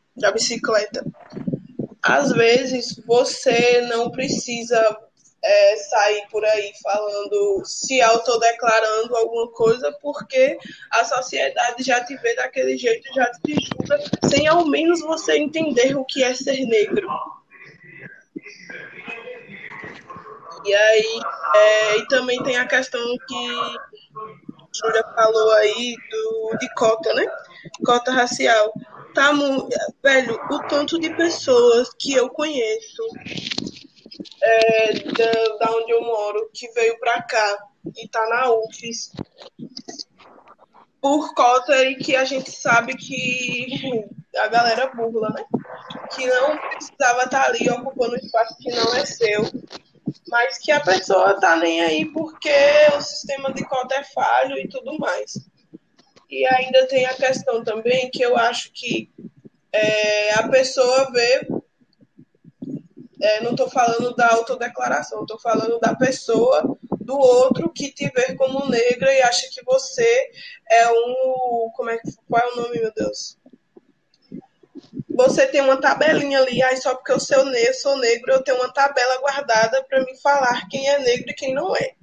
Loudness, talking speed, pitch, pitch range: -19 LUFS, 140 wpm, 250 Hz, 230-280 Hz